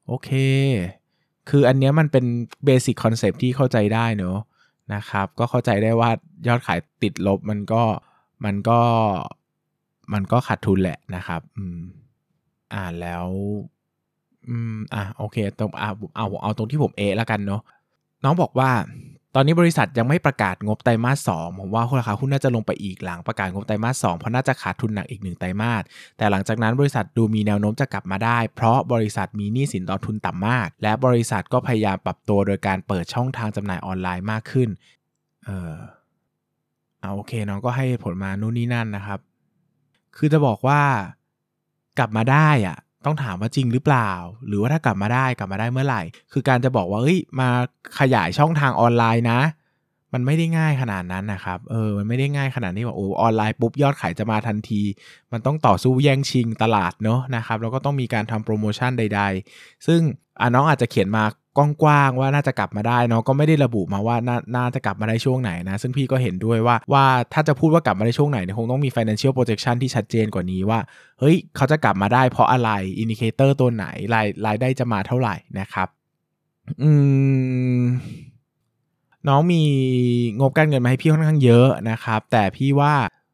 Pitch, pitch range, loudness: 115 Hz, 105-135 Hz, -21 LUFS